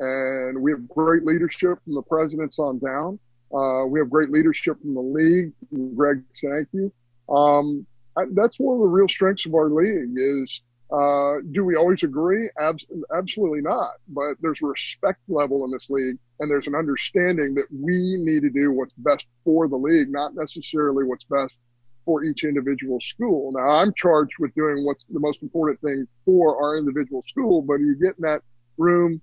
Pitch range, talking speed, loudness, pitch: 135-165 Hz, 185 wpm, -22 LUFS, 150 Hz